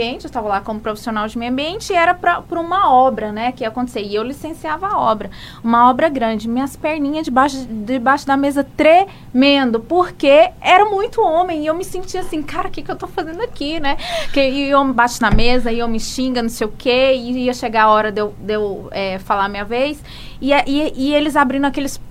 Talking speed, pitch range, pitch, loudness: 225 wpm, 235-320 Hz, 275 Hz, -17 LUFS